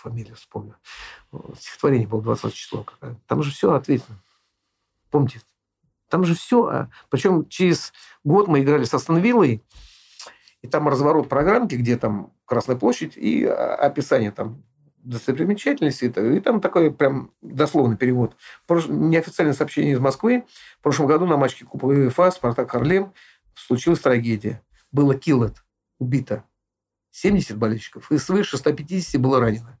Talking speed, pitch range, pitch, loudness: 130 wpm, 115-165 Hz, 140 Hz, -21 LUFS